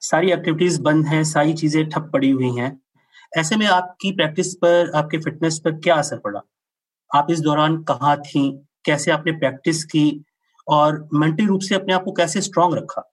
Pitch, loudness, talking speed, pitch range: 160 Hz, -19 LUFS, 185 wpm, 150-175 Hz